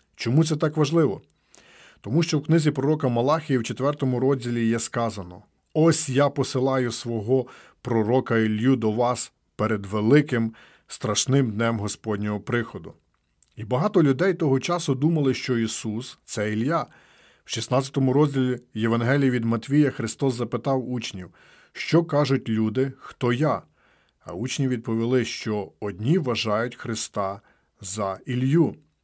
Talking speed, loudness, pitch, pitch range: 130 wpm, -24 LUFS, 125 Hz, 115-140 Hz